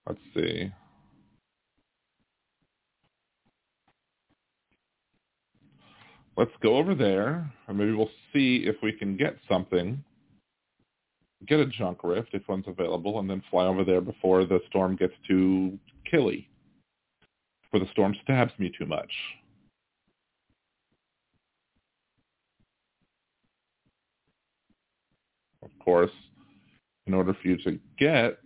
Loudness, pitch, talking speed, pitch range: -27 LUFS, 95 Hz, 100 wpm, 90-110 Hz